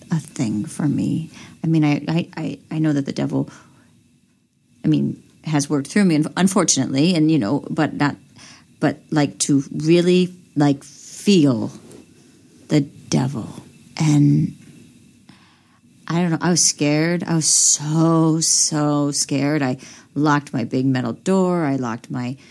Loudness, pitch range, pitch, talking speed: -19 LUFS, 140-165 Hz, 150 Hz, 145 wpm